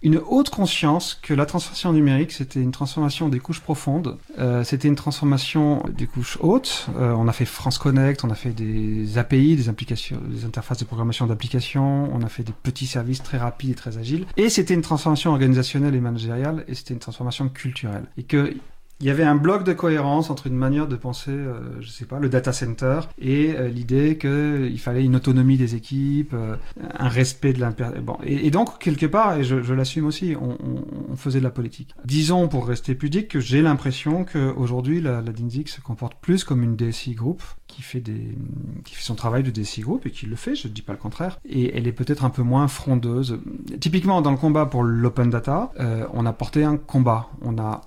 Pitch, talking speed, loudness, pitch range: 130 Hz, 220 wpm, -22 LUFS, 120-150 Hz